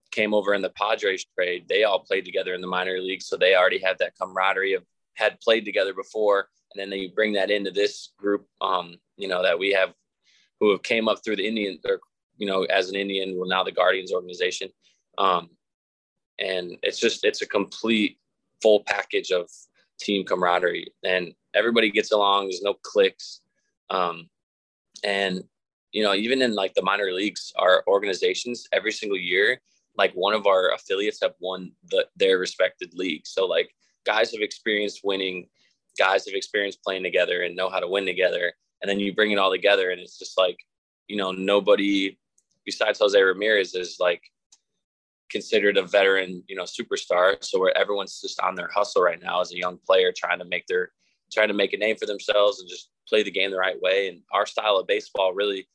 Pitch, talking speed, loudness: 350 Hz, 195 wpm, -24 LUFS